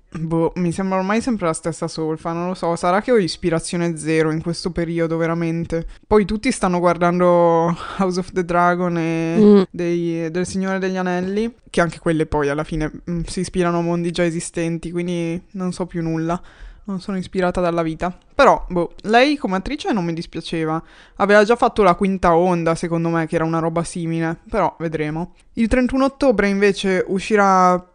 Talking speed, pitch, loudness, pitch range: 180 wpm, 175 Hz, -19 LUFS, 165-190 Hz